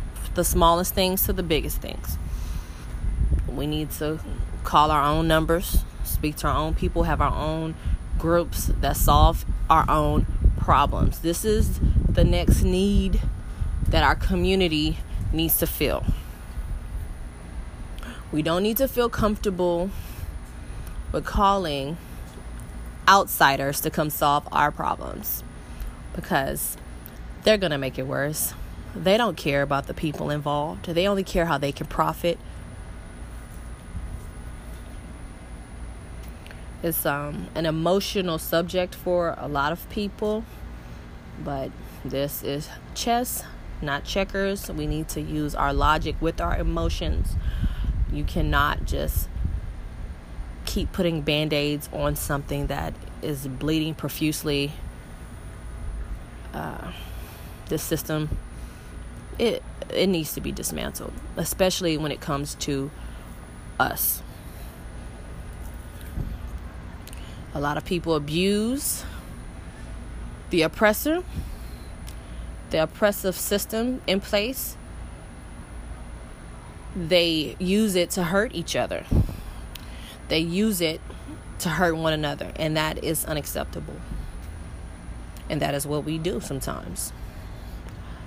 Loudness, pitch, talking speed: -25 LUFS, 135 Hz, 110 wpm